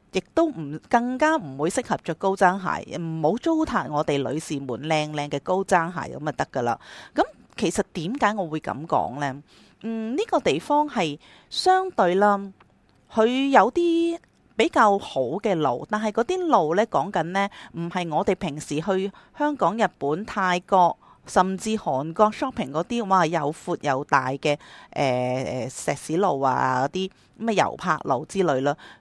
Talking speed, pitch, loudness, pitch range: 245 characters per minute, 185 Hz, -24 LUFS, 155-225 Hz